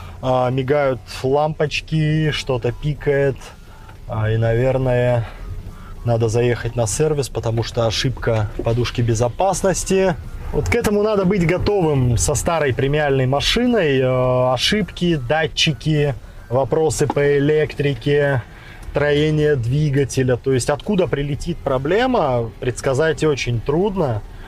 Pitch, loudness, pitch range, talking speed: 135 Hz, -19 LUFS, 120-150 Hz, 100 wpm